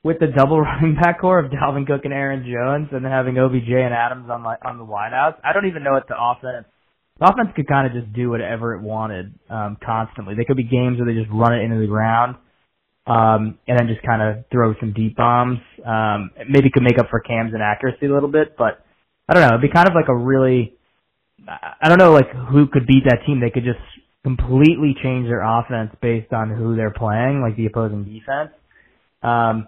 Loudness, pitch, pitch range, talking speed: -18 LUFS, 120 Hz, 115-135 Hz, 230 wpm